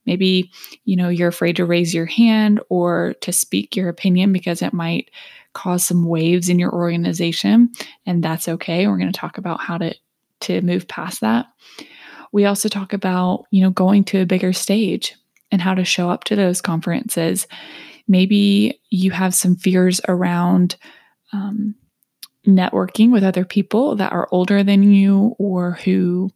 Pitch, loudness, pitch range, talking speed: 185 Hz, -17 LUFS, 175-205 Hz, 170 wpm